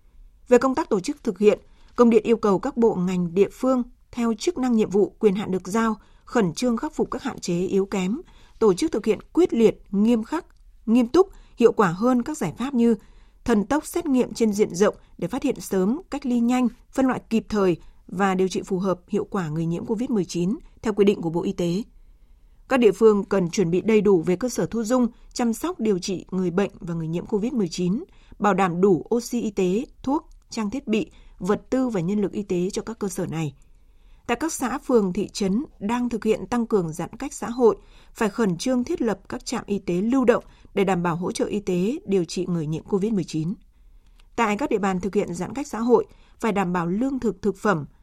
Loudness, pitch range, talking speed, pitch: -23 LUFS, 190-240 Hz, 230 wpm, 210 Hz